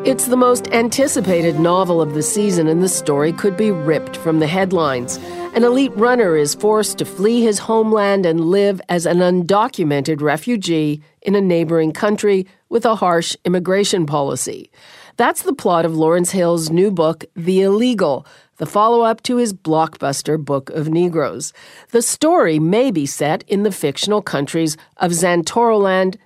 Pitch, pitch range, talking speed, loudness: 180 Hz, 160-215 Hz, 160 wpm, -16 LUFS